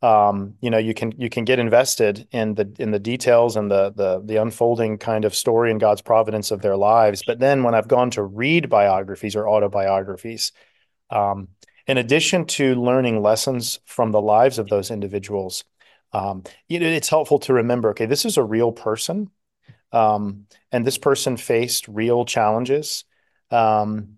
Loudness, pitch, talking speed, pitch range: -20 LUFS, 115 Hz, 180 wpm, 105-125 Hz